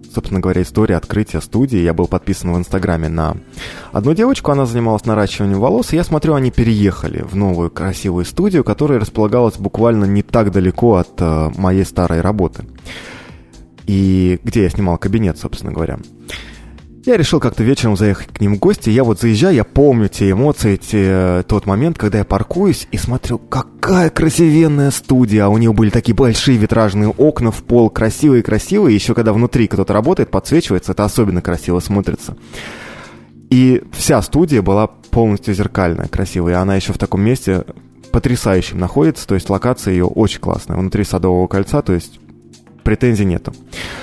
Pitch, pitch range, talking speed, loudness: 105 Hz, 95-120 Hz, 160 wpm, -14 LUFS